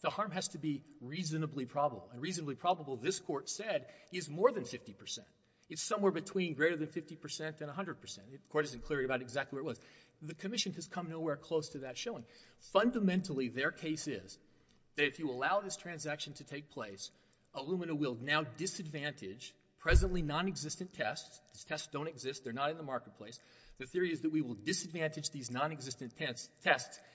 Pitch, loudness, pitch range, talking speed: 155 Hz, -38 LUFS, 135-170 Hz, 185 wpm